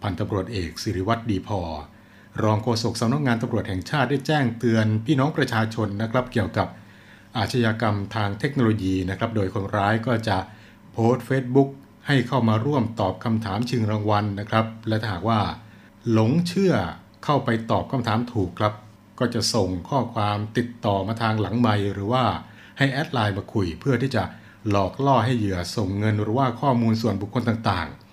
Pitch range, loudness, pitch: 100-120 Hz, -24 LUFS, 110 Hz